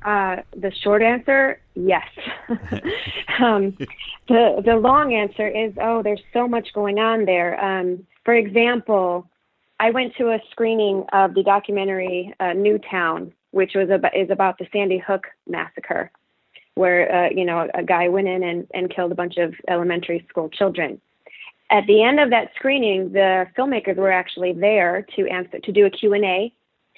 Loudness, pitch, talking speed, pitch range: -20 LUFS, 195 Hz, 165 wpm, 185-220 Hz